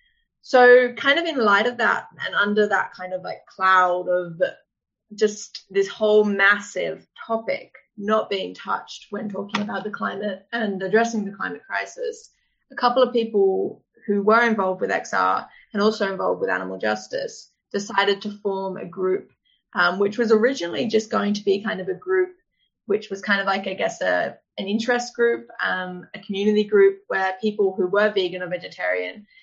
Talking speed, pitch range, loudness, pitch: 175 wpm, 195-235 Hz, -22 LUFS, 210 Hz